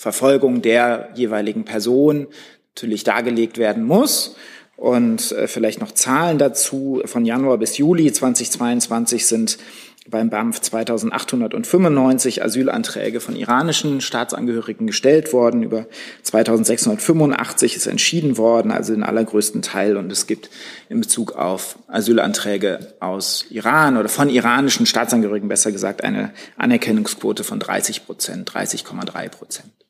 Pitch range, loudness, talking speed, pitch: 115-150 Hz, -18 LUFS, 120 wpm, 120 Hz